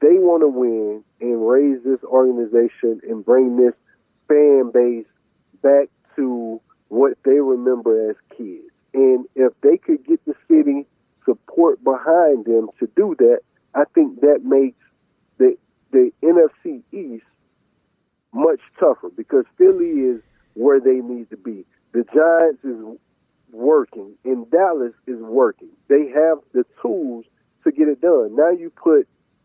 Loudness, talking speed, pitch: -17 LUFS, 145 wpm, 145 Hz